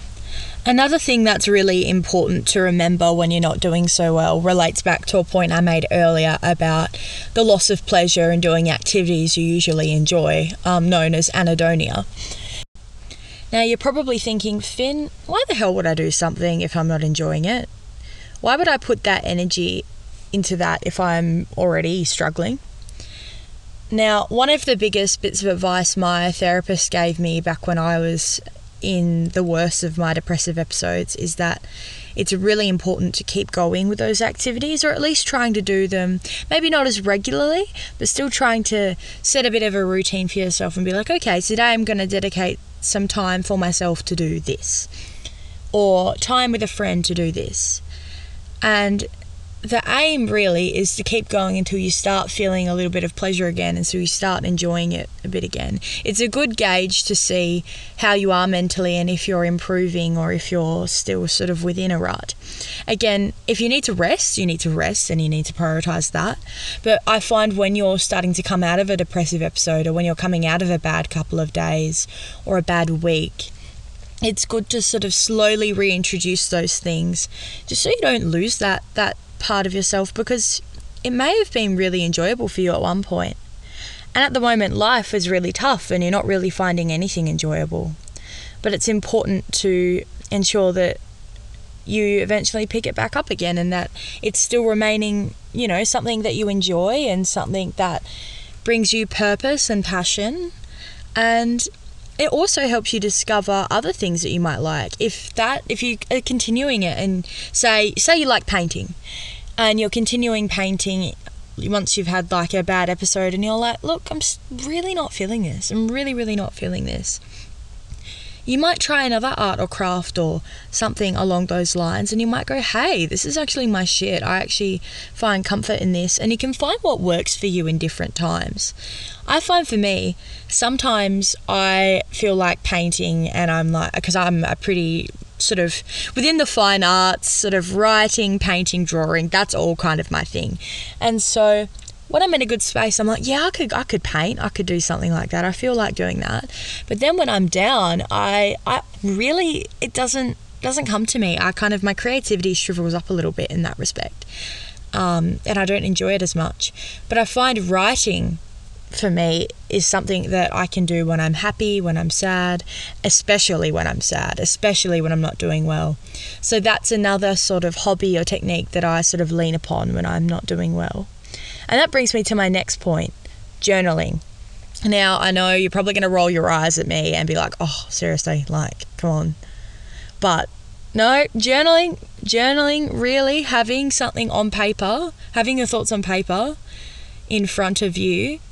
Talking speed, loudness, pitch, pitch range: 190 wpm, -19 LUFS, 185 Hz, 170-215 Hz